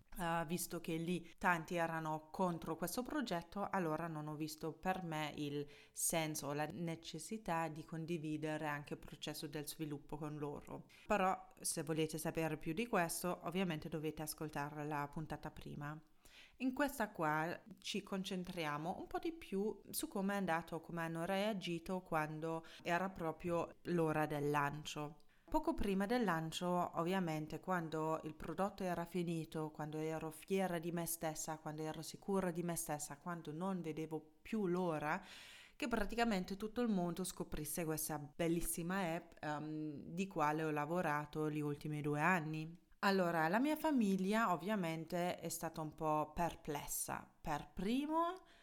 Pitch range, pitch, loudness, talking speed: 155-185 Hz, 165 Hz, -41 LUFS, 150 wpm